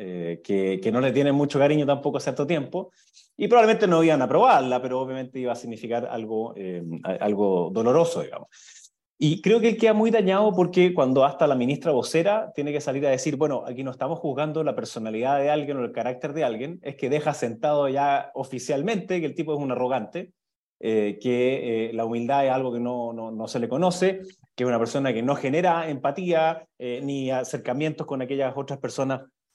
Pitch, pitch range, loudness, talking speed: 140 Hz, 125-160 Hz, -24 LUFS, 205 wpm